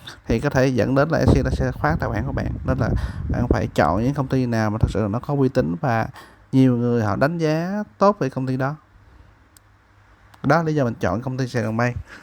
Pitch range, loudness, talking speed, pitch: 105-135 Hz, -21 LUFS, 250 wpm, 125 Hz